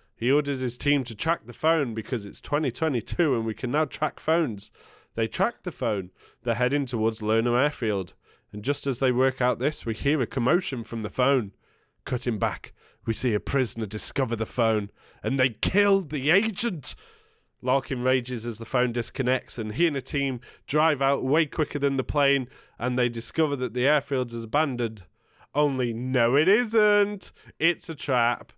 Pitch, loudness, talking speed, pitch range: 130 Hz, -26 LUFS, 185 wpm, 115-145 Hz